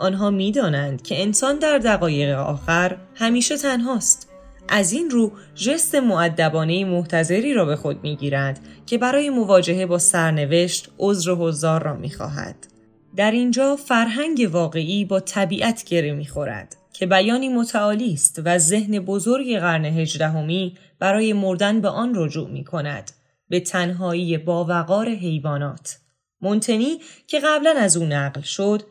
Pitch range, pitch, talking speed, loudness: 160-230 Hz, 185 Hz, 140 wpm, -20 LUFS